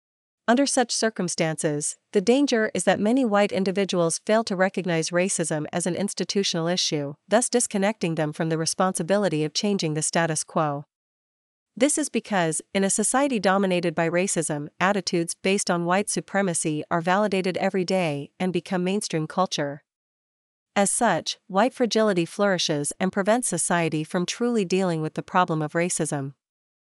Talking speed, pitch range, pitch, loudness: 150 wpm, 160-200 Hz, 185 Hz, -24 LUFS